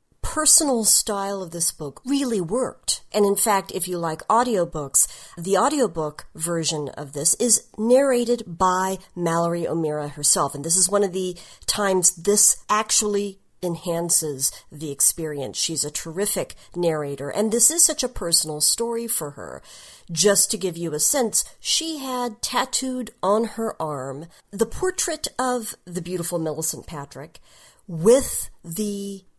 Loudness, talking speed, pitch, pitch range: -21 LUFS, 145 wpm, 185 Hz, 160-225 Hz